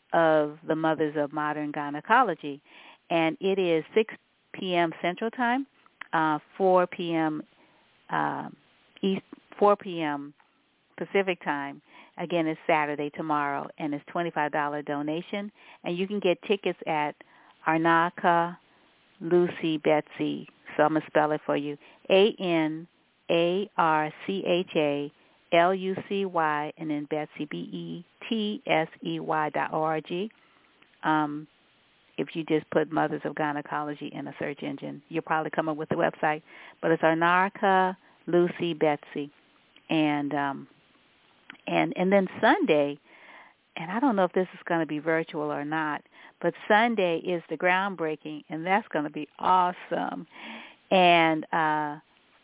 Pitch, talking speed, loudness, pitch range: 160 Hz, 145 wpm, -27 LUFS, 150-185 Hz